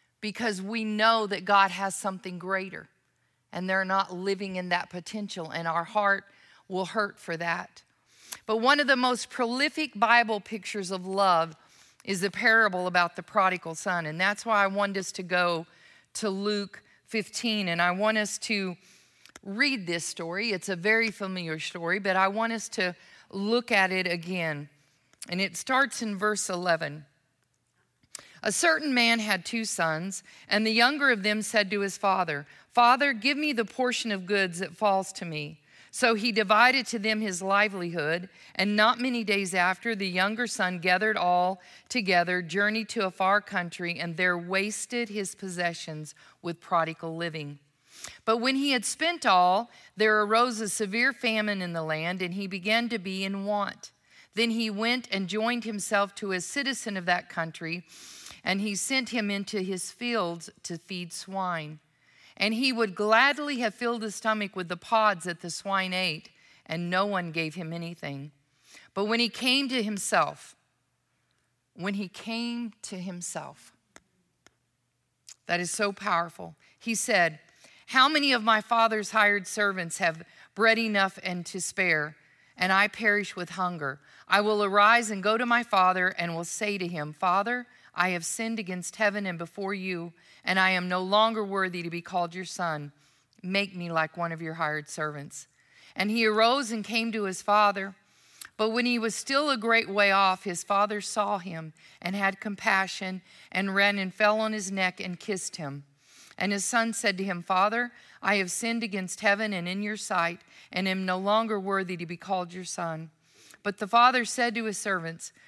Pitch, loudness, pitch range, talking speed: 195 Hz, -27 LUFS, 175-220 Hz, 180 wpm